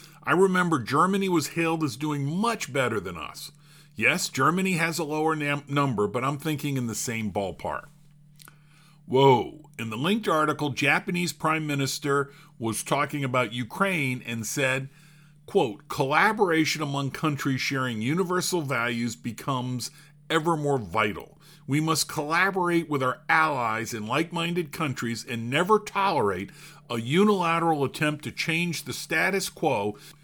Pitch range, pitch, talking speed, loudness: 130-165 Hz, 150 Hz, 140 wpm, -26 LUFS